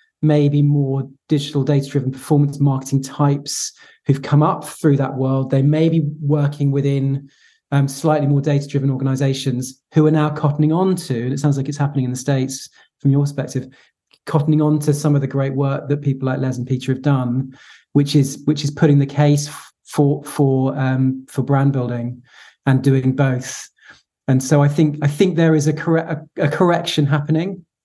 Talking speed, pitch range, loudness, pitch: 185 wpm, 135-150 Hz, -18 LUFS, 140 Hz